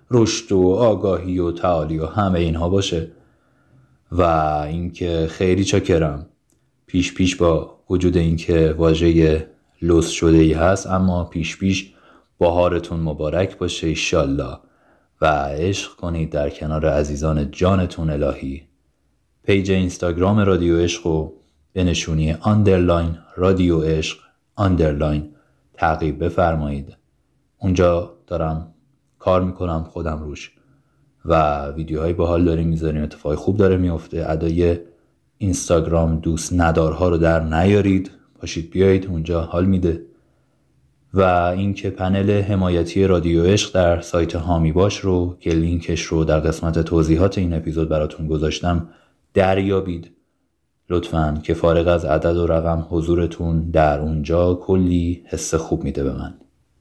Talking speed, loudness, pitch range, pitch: 125 wpm, -19 LUFS, 80-90 Hz, 85 Hz